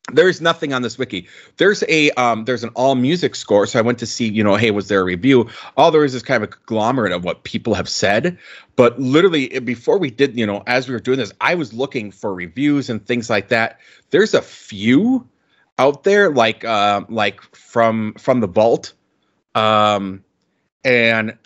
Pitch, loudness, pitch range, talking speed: 120 Hz, -17 LUFS, 110-135 Hz, 205 wpm